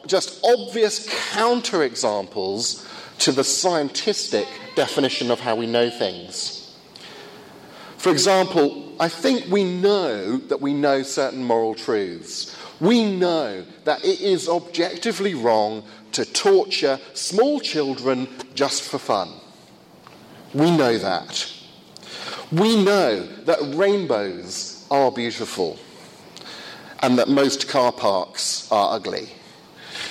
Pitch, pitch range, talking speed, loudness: 170 Hz, 135-210 Hz, 110 wpm, -21 LUFS